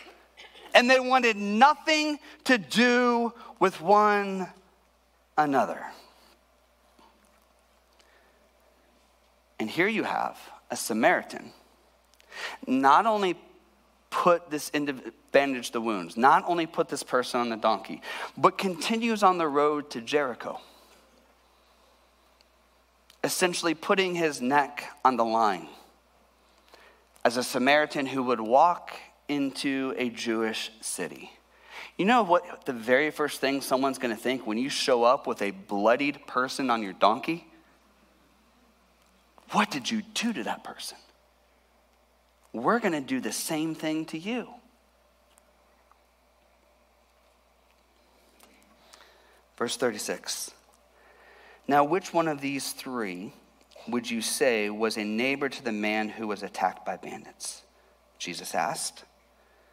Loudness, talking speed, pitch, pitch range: -26 LUFS, 115 wpm, 150 Hz, 120-205 Hz